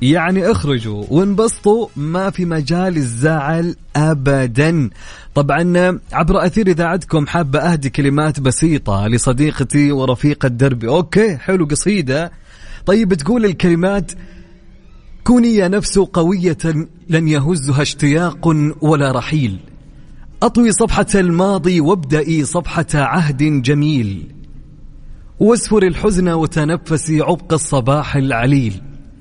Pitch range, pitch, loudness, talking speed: 145-180 Hz, 160 Hz, -15 LUFS, 95 wpm